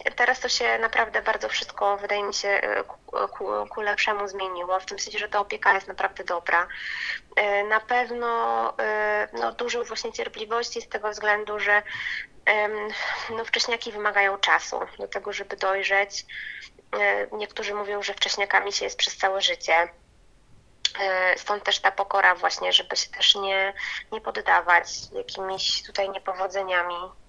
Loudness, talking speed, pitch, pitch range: -24 LUFS, 140 wpm, 205 Hz, 195-220 Hz